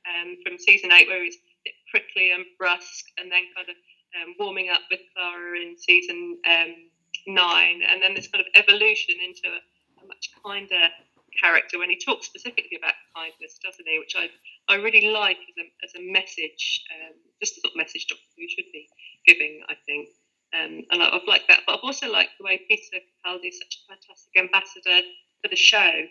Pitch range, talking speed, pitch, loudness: 175-235 Hz, 205 wpm, 185 Hz, -20 LUFS